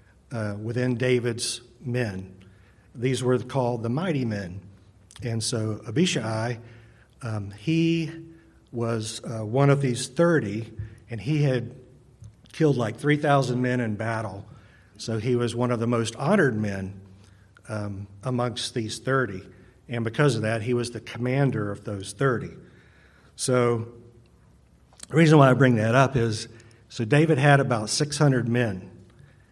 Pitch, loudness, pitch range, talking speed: 120 Hz, -25 LUFS, 110-130 Hz, 140 wpm